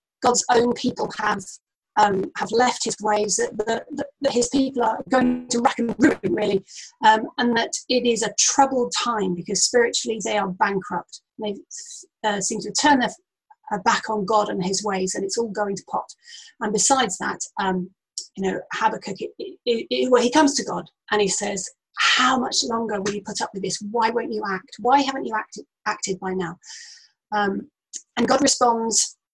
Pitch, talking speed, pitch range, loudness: 225 Hz, 190 wpm, 205-265 Hz, -22 LUFS